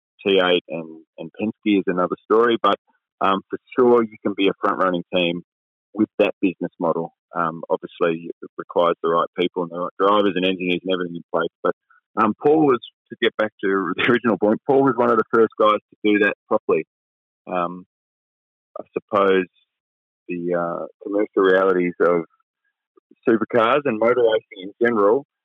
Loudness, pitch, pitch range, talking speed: -20 LUFS, 95 Hz, 90-110 Hz, 175 wpm